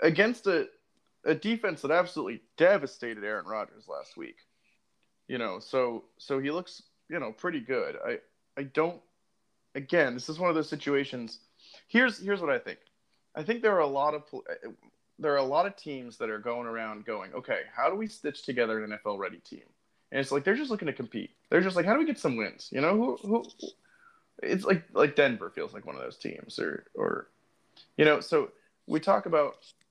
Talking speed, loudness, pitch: 205 wpm, -30 LUFS, 180 Hz